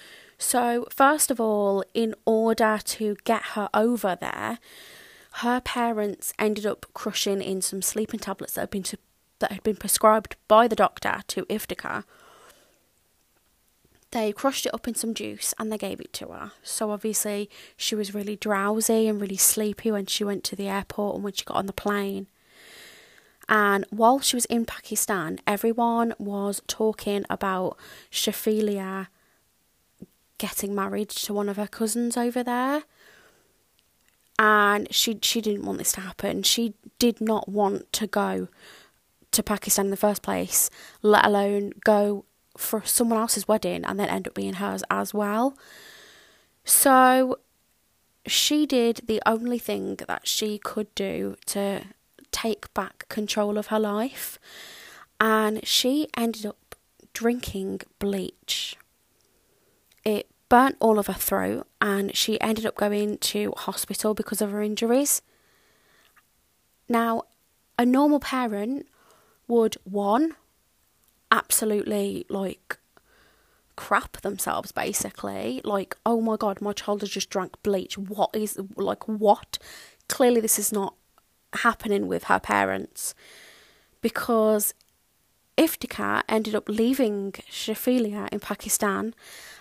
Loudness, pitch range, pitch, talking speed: -25 LUFS, 205-230 Hz, 215 Hz, 135 wpm